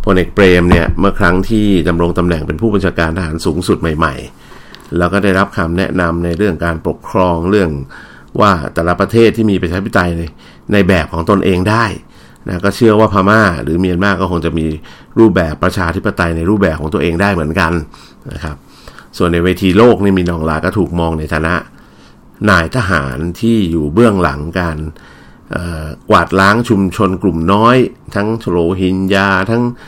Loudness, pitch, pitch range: -13 LUFS, 90 Hz, 85-100 Hz